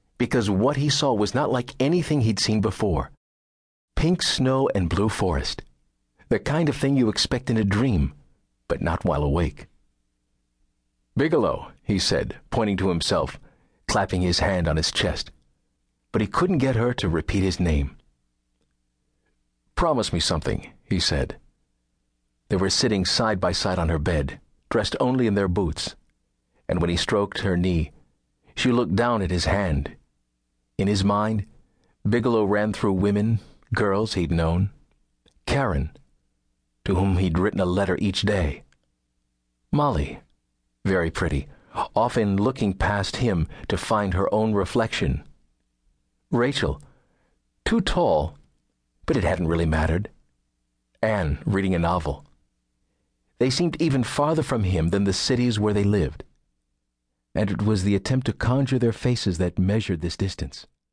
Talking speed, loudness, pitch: 145 wpm, -24 LUFS, 90 Hz